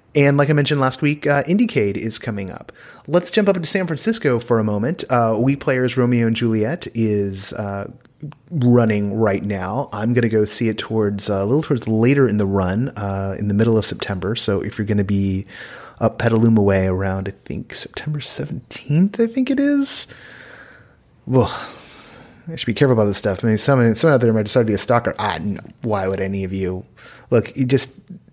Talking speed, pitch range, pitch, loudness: 210 wpm, 105-140 Hz, 115 Hz, -19 LUFS